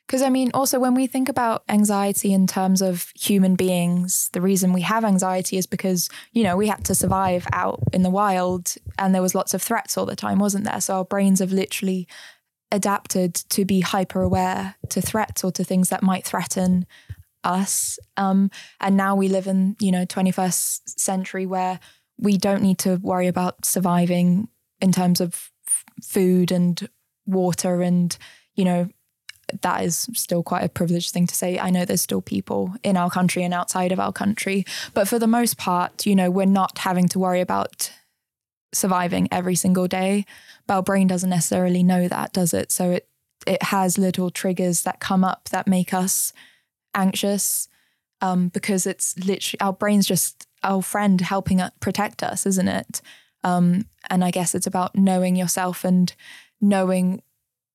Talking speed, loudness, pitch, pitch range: 180 wpm, -21 LUFS, 185 Hz, 180-195 Hz